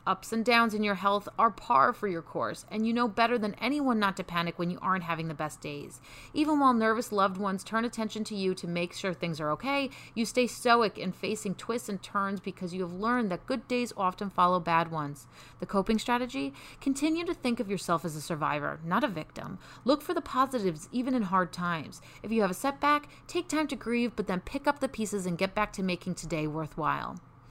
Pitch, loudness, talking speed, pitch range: 205 Hz, -30 LUFS, 230 wpm, 180-245 Hz